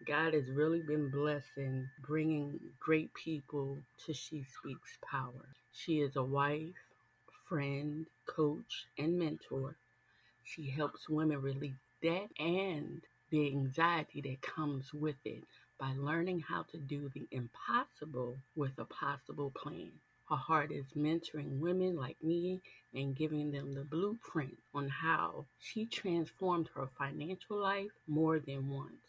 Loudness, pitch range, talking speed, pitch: -39 LUFS, 140-160 Hz, 135 wpm, 150 Hz